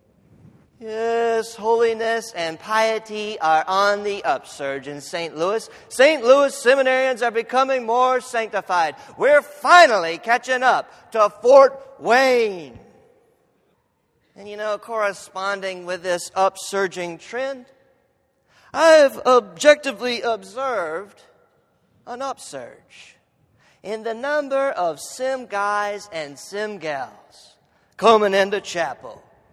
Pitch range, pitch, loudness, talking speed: 200-265 Hz, 225 Hz, -19 LUFS, 100 wpm